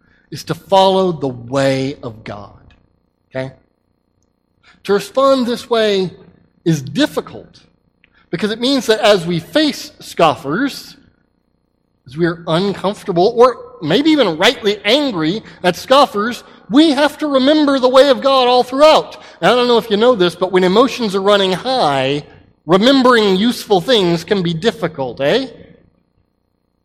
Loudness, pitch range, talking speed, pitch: -14 LUFS, 155-255 Hz, 145 wpm, 200 Hz